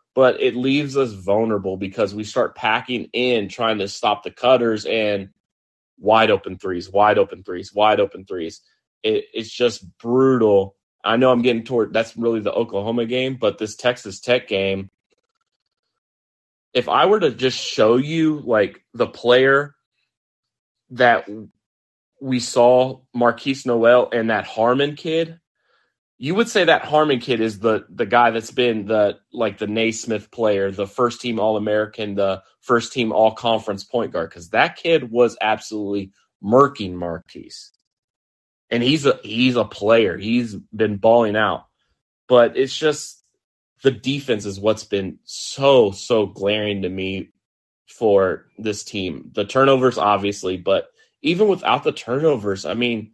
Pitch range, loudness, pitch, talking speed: 105-130 Hz, -19 LUFS, 115 Hz, 150 wpm